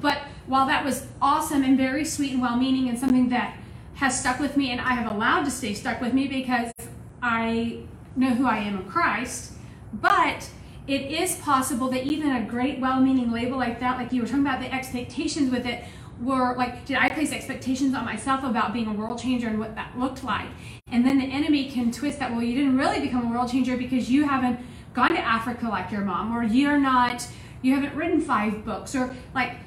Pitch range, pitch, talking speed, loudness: 240-275 Hz, 255 Hz, 215 wpm, -25 LUFS